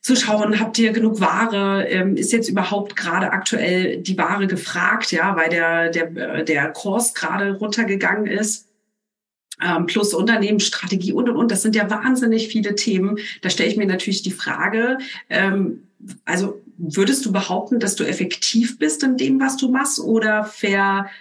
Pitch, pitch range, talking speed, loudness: 205 Hz, 190-225 Hz, 160 wpm, -19 LUFS